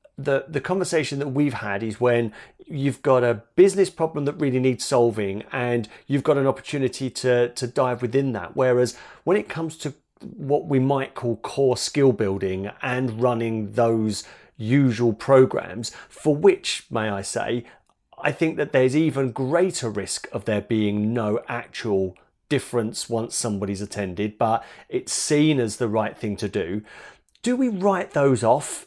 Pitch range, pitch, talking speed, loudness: 110-145 Hz, 125 Hz, 165 wpm, -23 LUFS